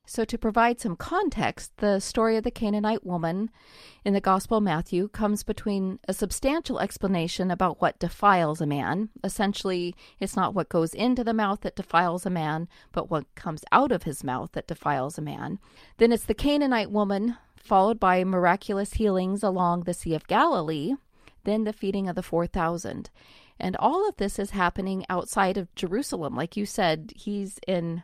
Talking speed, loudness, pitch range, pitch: 180 wpm, -26 LUFS, 175-215 Hz, 195 Hz